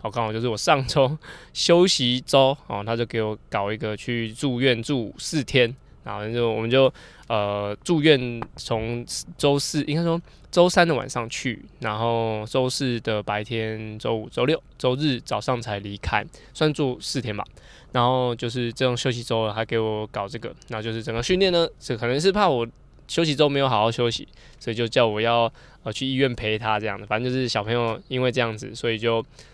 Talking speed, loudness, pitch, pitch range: 280 characters per minute, -23 LUFS, 120 Hz, 110-135 Hz